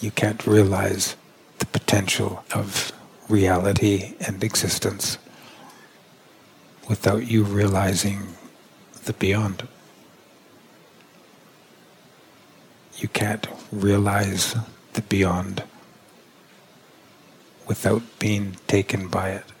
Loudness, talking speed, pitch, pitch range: -23 LUFS, 75 wpm, 100 Hz, 95-105 Hz